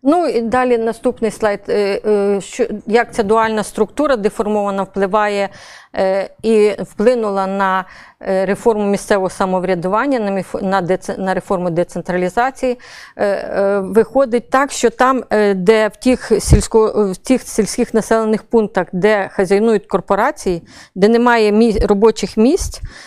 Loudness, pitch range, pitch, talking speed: -15 LUFS, 195-230 Hz, 210 Hz, 110 wpm